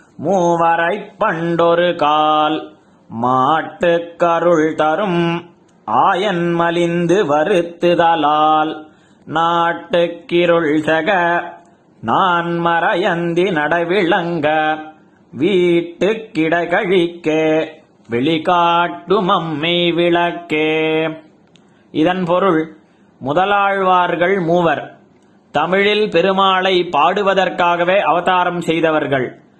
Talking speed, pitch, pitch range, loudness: 50 wpm, 170 Hz, 160-175 Hz, -15 LUFS